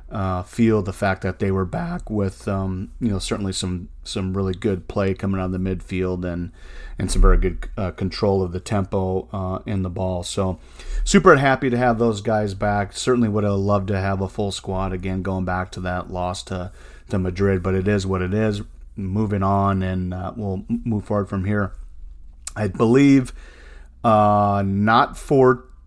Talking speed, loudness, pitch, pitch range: 195 wpm, -21 LUFS, 95 Hz, 95-105 Hz